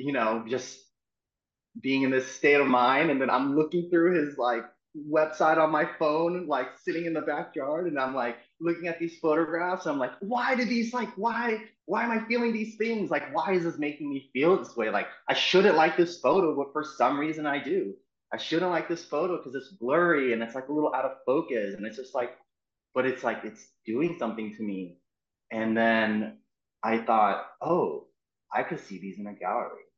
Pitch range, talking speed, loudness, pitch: 125-170 Hz, 210 wpm, -27 LUFS, 150 Hz